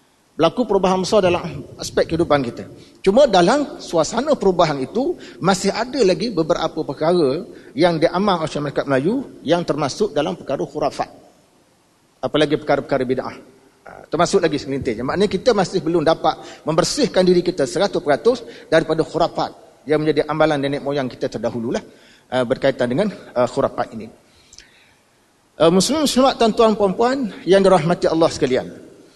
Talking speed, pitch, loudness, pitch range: 130 wpm, 170 Hz, -19 LUFS, 145-200 Hz